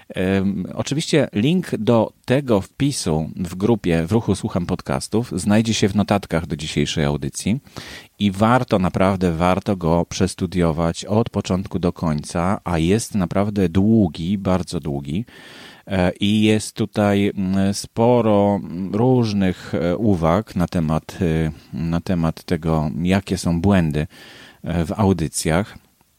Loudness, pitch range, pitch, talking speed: -20 LUFS, 85-105 Hz, 95 Hz, 115 wpm